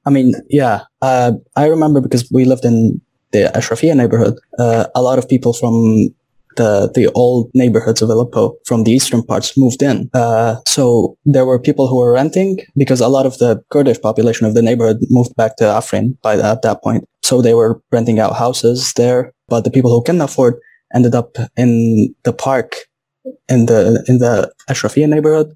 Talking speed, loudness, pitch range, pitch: 195 wpm, -13 LUFS, 115-135 Hz, 125 Hz